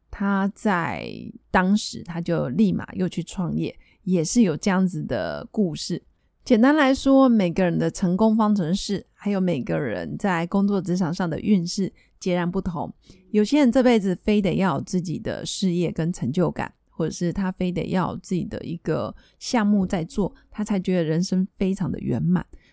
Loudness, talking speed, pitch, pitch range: -23 LUFS, 260 characters per minute, 190 Hz, 175-210 Hz